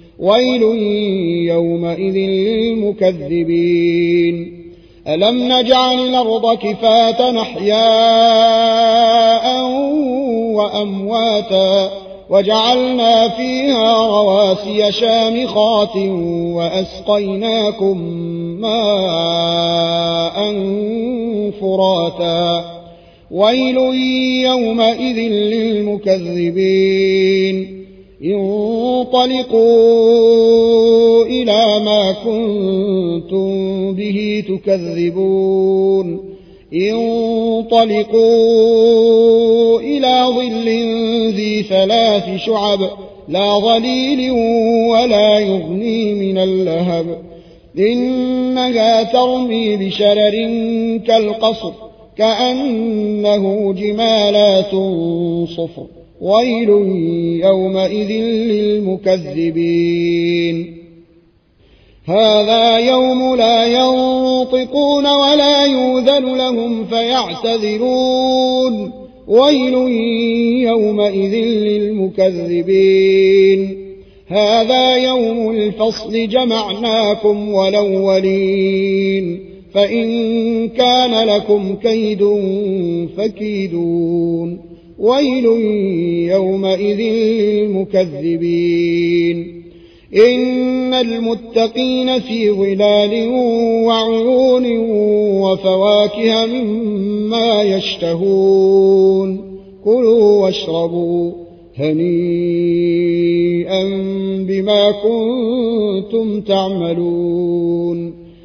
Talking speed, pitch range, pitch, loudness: 45 wpm, 190-230 Hz, 210 Hz, -14 LUFS